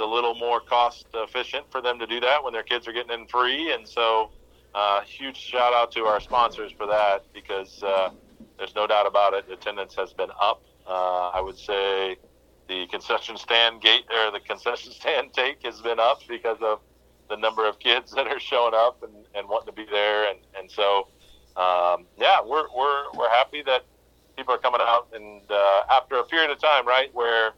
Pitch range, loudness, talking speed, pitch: 100-120 Hz, -24 LUFS, 205 wpm, 110 Hz